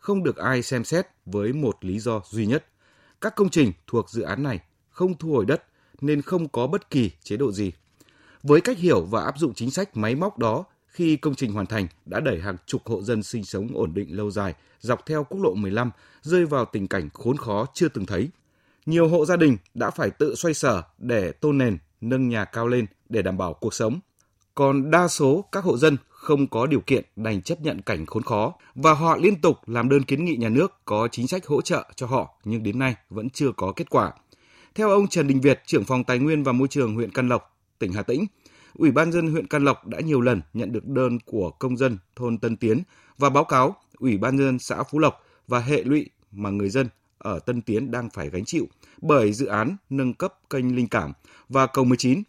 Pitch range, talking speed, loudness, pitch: 110-150 Hz, 235 wpm, -24 LUFS, 130 Hz